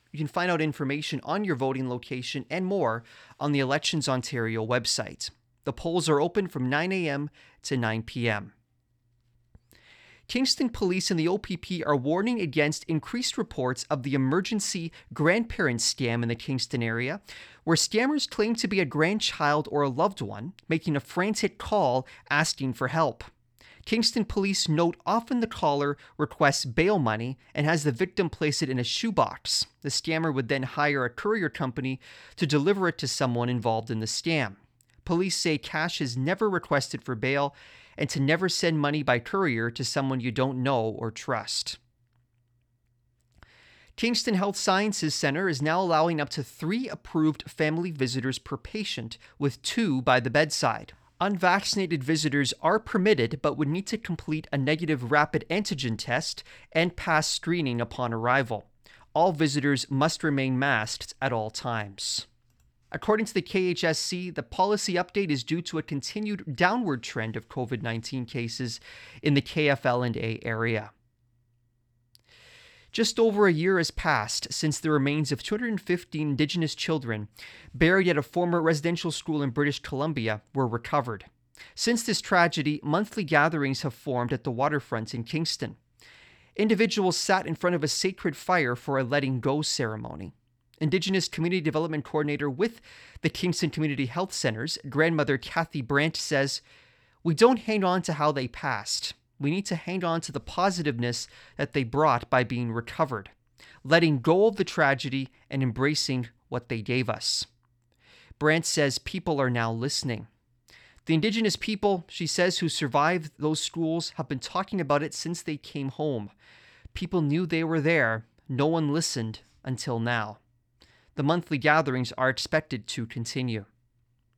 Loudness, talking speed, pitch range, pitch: -27 LUFS, 155 wpm, 125-170 Hz, 145 Hz